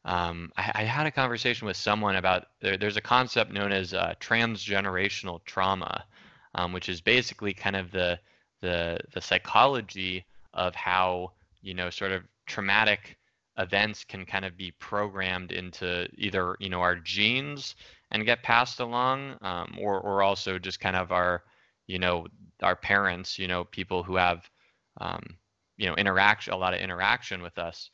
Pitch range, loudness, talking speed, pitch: 90-105 Hz, -28 LUFS, 170 wpm, 95 Hz